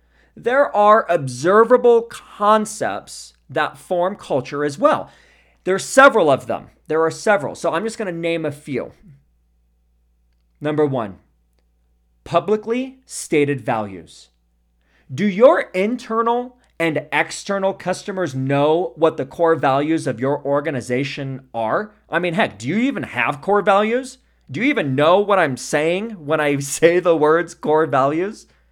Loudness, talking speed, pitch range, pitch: -18 LUFS, 140 wpm, 130-205 Hz, 155 Hz